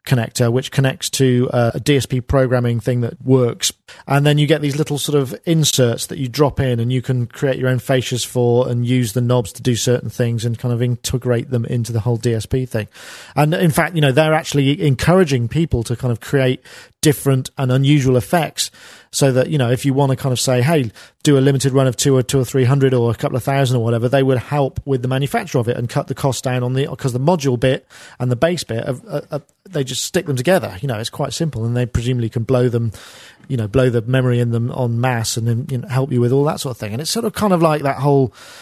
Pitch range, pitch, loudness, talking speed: 120-140 Hz, 130 Hz, -17 LUFS, 260 wpm